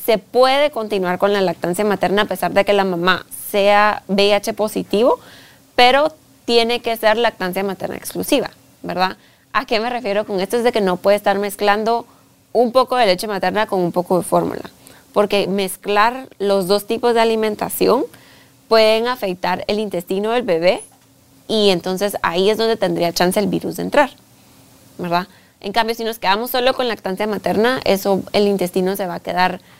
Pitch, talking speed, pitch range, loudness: 205 Hz, 175 wpm, 190-225 Hz, -17 LUFS